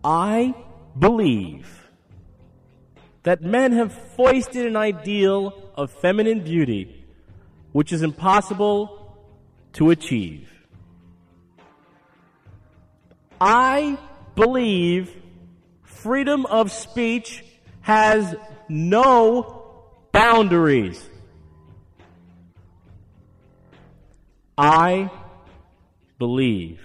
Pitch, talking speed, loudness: 150 Hz, 60 wpm, -19 LUFS